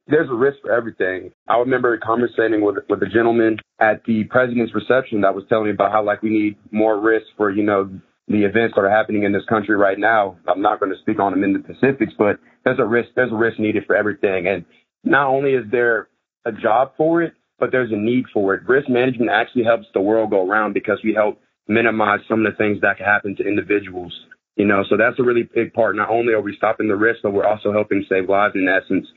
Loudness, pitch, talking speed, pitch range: -18 LUFS, 110 Hz, 245 wpm, 105-115 Hz